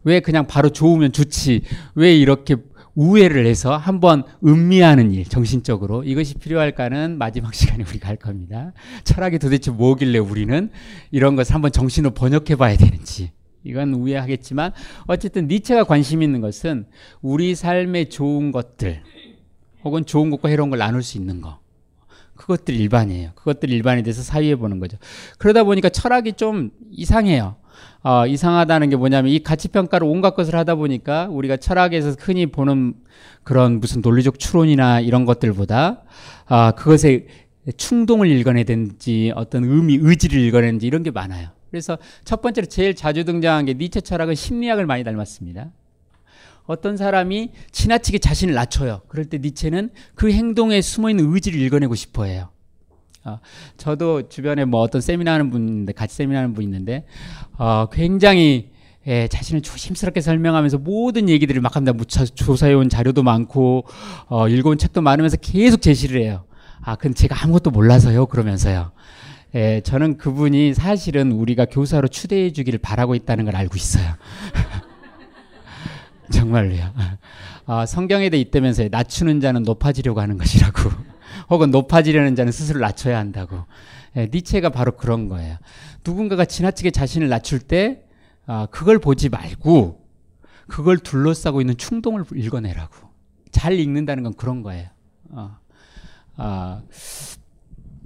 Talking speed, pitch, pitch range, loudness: 350 characters per minute, 135 Hz, 115-160 Hz, -18 LUFS